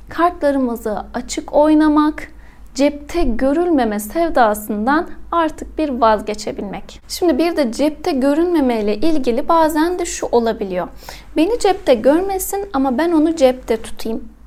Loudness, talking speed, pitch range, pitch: -17 LUFS, 115 wpm, 240-325 Hz, 290 Hz